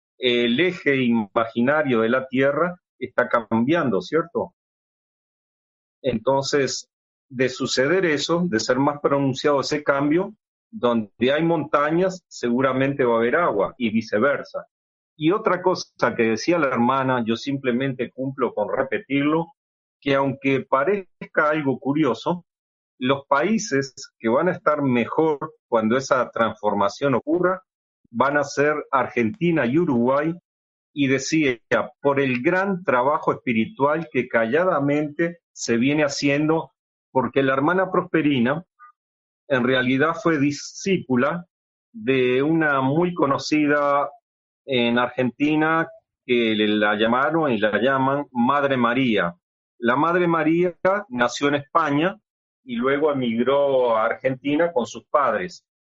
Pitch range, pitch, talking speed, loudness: 125-165 Hz, 140 Hz, 120 wpm, -21 LUFS